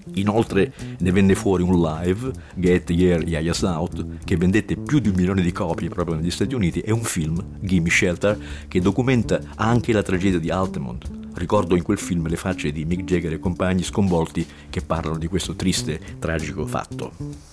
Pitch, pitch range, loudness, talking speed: 90 Hz, 85-100 Hz, -22 LUFS, 180 wpm